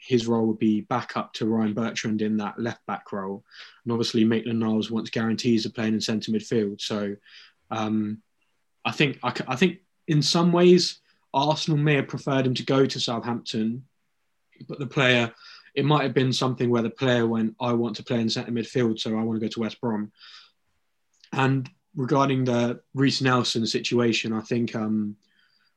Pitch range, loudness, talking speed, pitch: 110-135 Hz, -25 LUFS, 180 wpm, 120 Hz